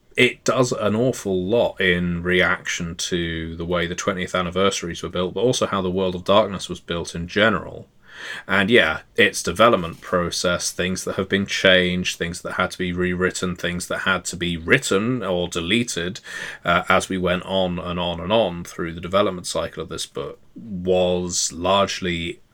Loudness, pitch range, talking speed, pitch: -21 LUFS, 85-95 Hz, 180 wpm, 90 Hz